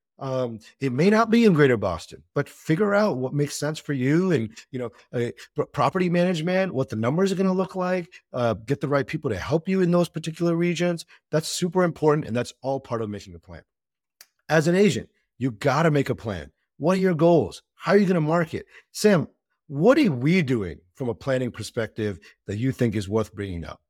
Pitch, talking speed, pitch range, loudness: 145 Hz, 220 wpm, 120-175 Hz, -24 LUFS